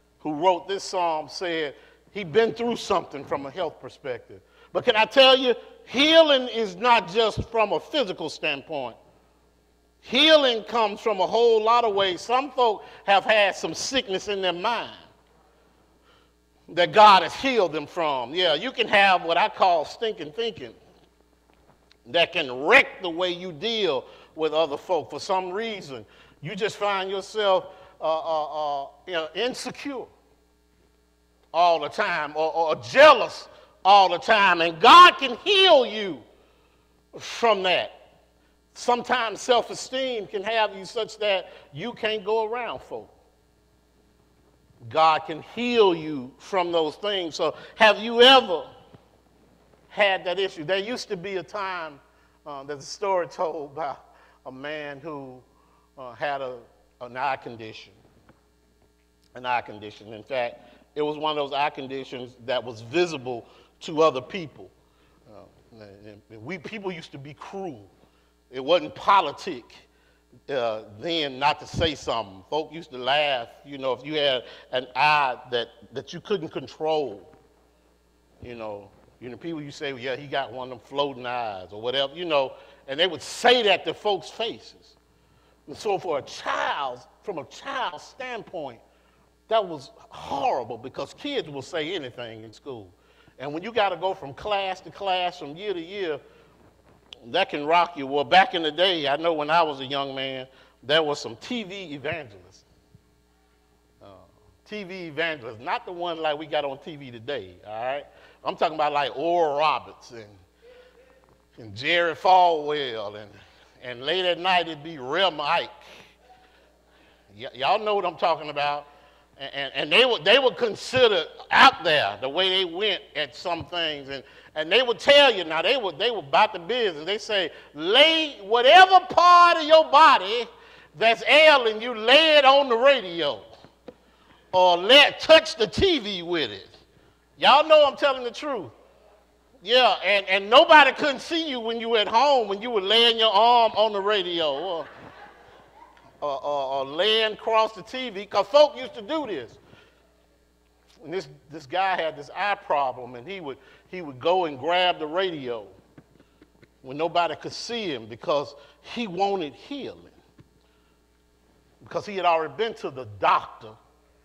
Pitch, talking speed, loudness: 170 Hz, 165 wpm, -22 LUFS